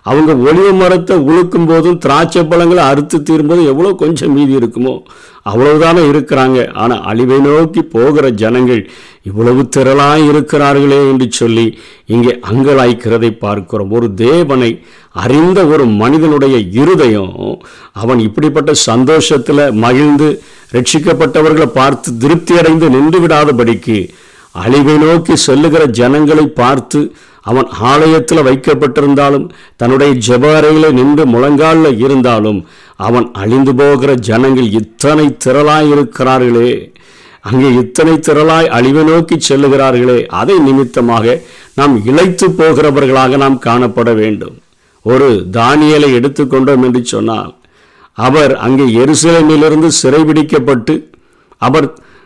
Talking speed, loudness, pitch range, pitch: 100 wpm, -8 LUFS, 125-155 Hz, 140 Hz